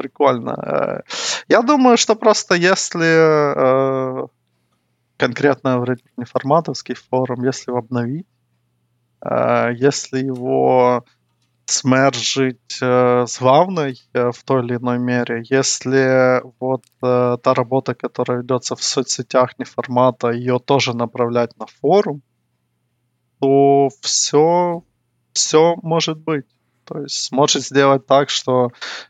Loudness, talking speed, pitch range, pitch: -17 LUFS, 110 wpm, 120-140 Hz, 130 Hz